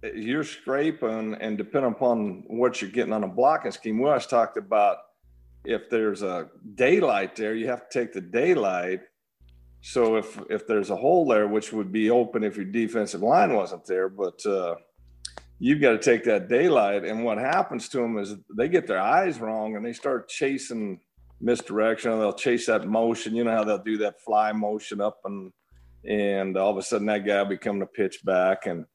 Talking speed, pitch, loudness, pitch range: 195 wpm, 105 Hz, -25 LUFS, 95-110 Hz